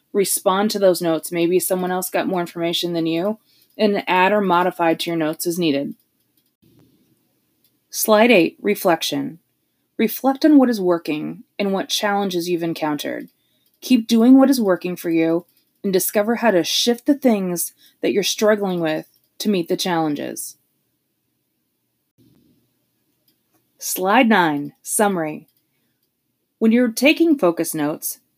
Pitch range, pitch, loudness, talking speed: 170-225 Hz, 185 Hz, -19 LUFS, 135 wpm